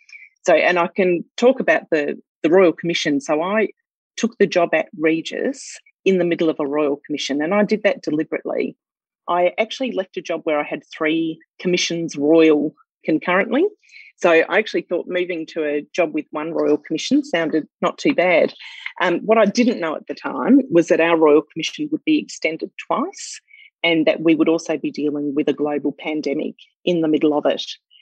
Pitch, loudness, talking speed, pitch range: 170 Hz, -19 LUFS, 195 wpm, 155-220 Hz